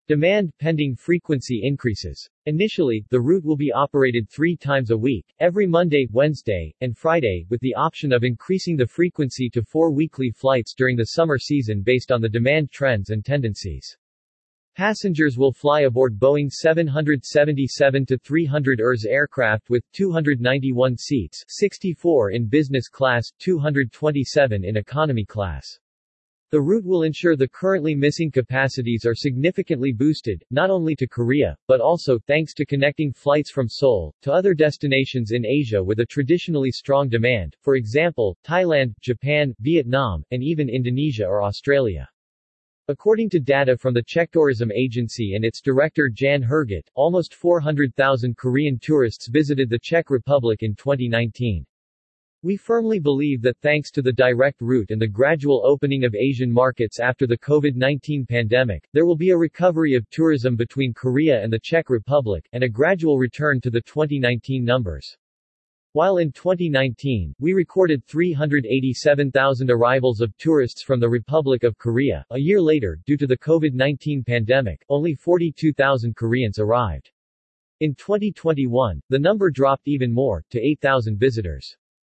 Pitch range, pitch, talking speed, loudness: 120-155 Hz, 135 Hz, 150 wpm, -20 LUFS